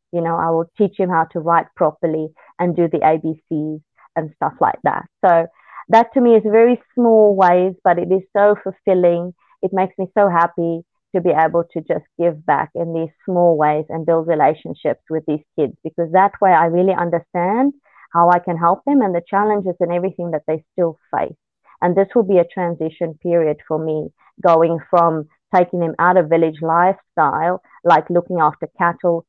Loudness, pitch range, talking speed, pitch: -17 LUFS, 165-190 Hz, 195 wpm, 170 Hz